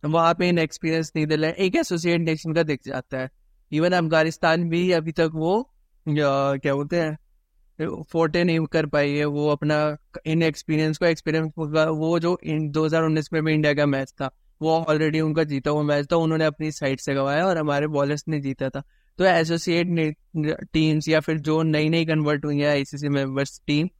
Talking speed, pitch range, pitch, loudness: 185 wpm, 150-165 Hz, 155 Hz, -23 LUFS